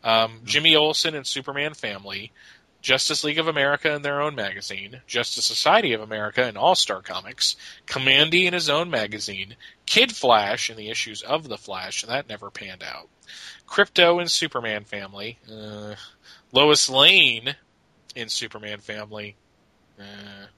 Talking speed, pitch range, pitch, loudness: 145 wpm, 105-150 Hz, 120 Hz, -20 LUFS